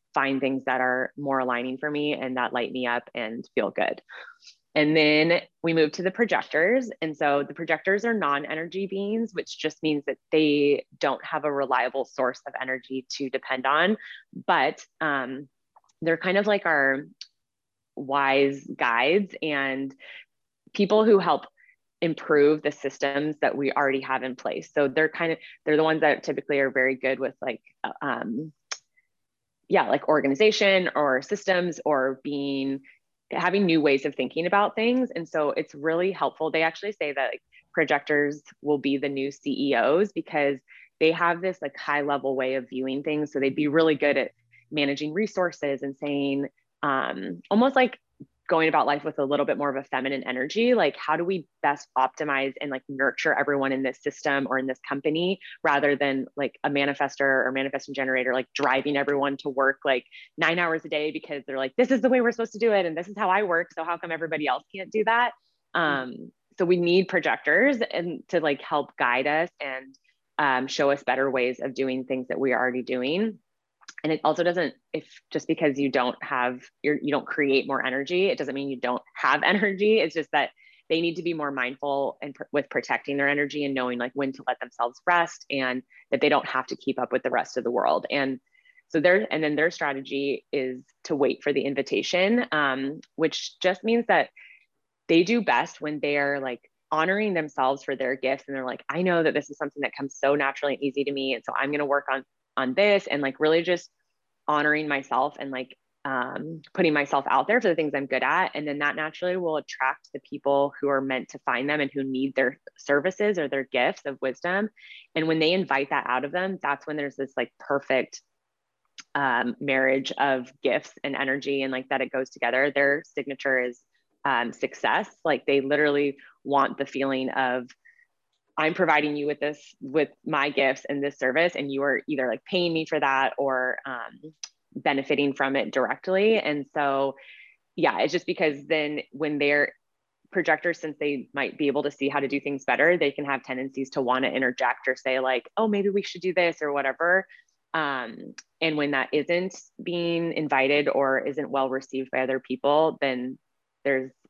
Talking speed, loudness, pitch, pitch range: 200 wpm, -25 LUFS, 145 Hz, 135-160 Hz